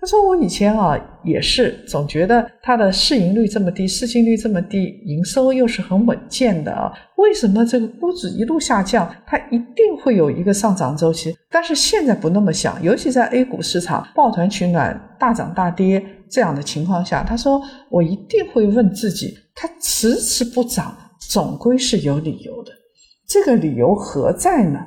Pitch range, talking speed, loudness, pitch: 185-255 Hz, 275 characters per minute, -17 LUFS, 225 Hz